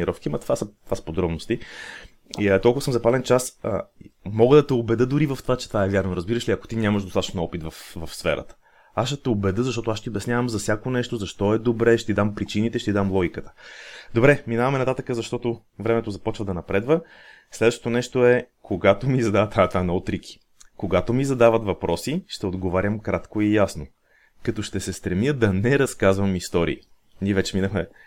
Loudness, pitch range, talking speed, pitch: -23 LUFS, 95-120 Hz, 195 wpm, 110 Hz